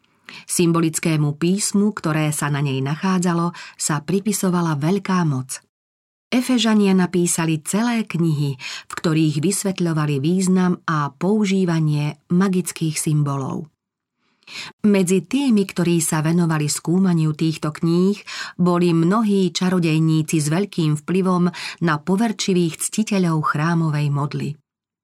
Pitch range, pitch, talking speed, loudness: 155-190 Hz, 170 Hz, 100 wpm, -20 LUFS